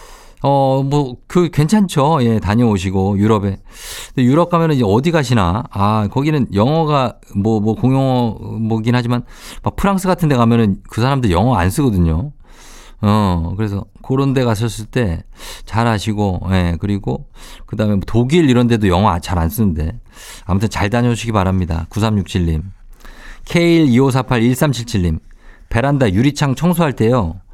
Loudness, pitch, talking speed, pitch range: -16 LUFS, 115 Hz, 280 characters per minute, 100-135 Hz